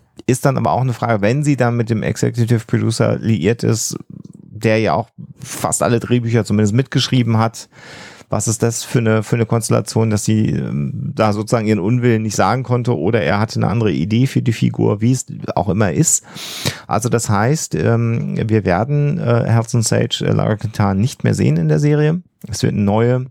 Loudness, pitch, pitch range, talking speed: -17 LUFS, 115 Hz, 110-130 Hz, 190 wpm